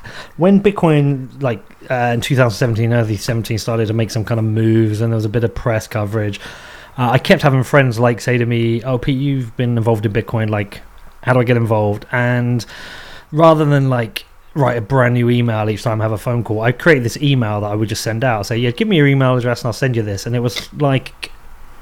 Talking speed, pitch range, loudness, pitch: 240 wpm, 110-130 Hz, -16 LUFS, 120 Hz